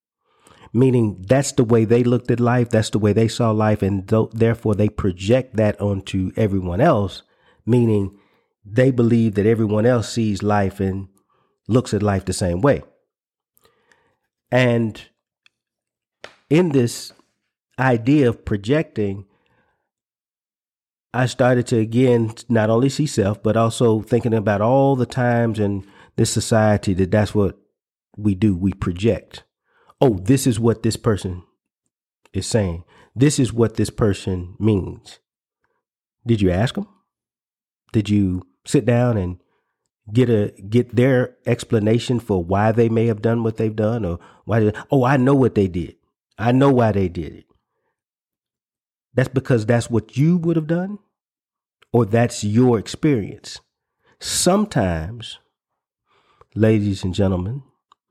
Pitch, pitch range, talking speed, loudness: 115 Hz, 100-125 Hz, 140 wpm, -19 LUFS